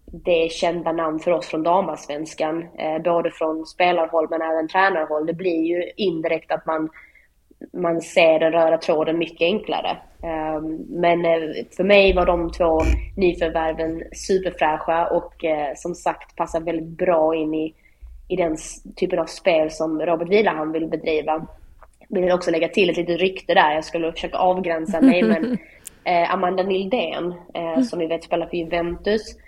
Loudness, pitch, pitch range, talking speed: -21 LUFS, 165 Hz, 160-175 Hz, 155 wpm